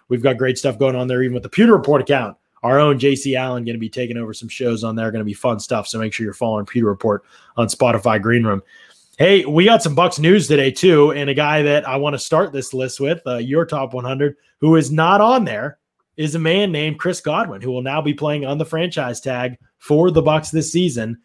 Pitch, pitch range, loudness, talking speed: 140 Hz, 125-155 Hz, -17 LUFS, 255 wpm